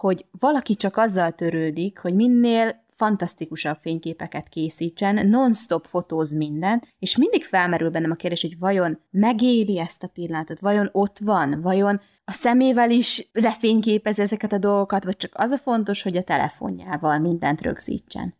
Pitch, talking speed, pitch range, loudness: 195 Hz, 150 wpm, 165-220 Hz, -22 LUFS